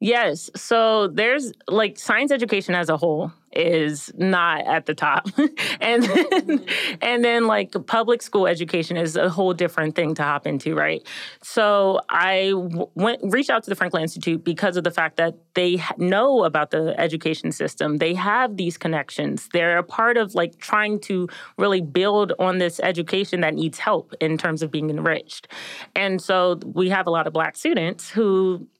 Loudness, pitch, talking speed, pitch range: -21 LUFS, 185 Hz, 175 wpm, 170-215 Hz